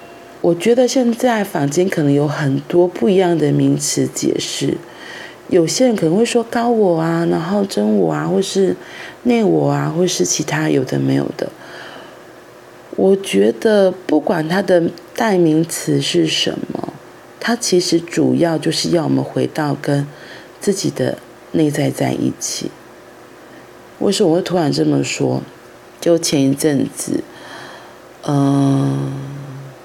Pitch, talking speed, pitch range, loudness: 165 Hz, 200 characters per minute, 140-190 Hz, -16 LUFS